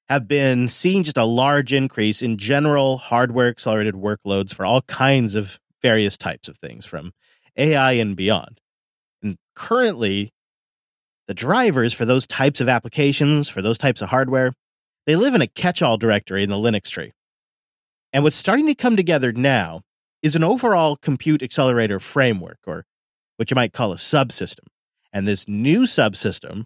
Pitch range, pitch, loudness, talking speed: 105-140 Hz, 125 Hz, -19 LUFS, 165 wpm